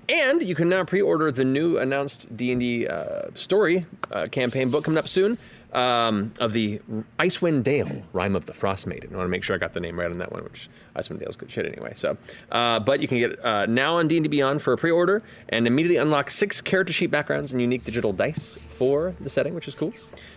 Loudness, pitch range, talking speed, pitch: -24 LUFS, 115-170 Hz, 240 wpm, 135 Hz